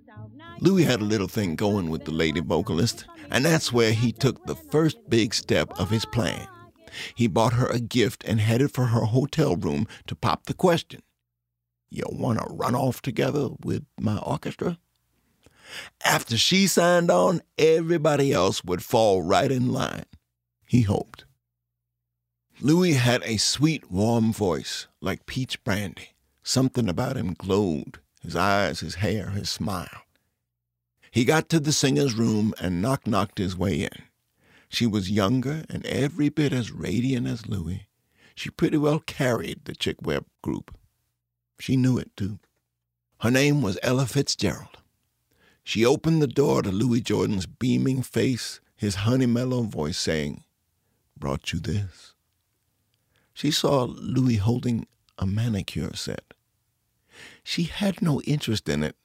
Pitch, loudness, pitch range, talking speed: 115 Hz, -24 LUFS, 95-130 Hz, 150 wpm